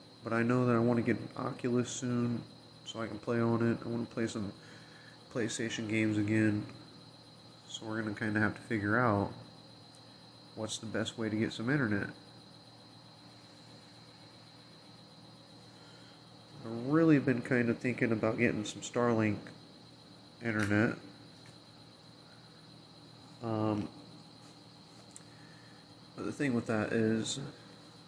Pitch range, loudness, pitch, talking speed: 110-130 Hz, -33 LUFS, 115 Hz, 130 wpm